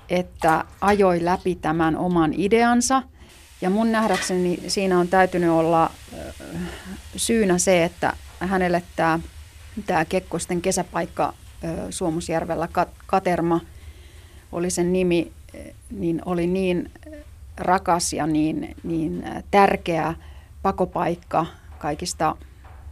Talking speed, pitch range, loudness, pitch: 90 wpm, 160-185 Hz, -22 LUFS, 175 Hz